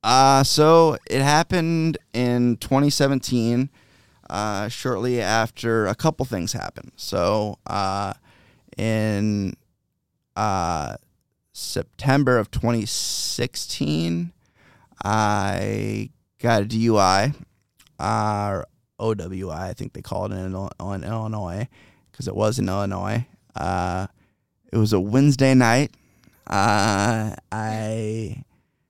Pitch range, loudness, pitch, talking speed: 100-125 Hz, -22 LUFS, 110 Hz, 100 wpm